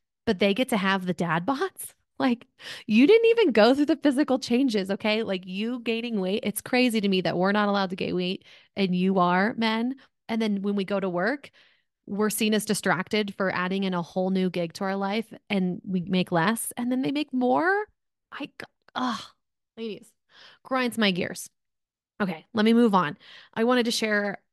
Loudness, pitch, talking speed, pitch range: -25 LUFS, 210 Hz, 200 wpm, 190-240 Hz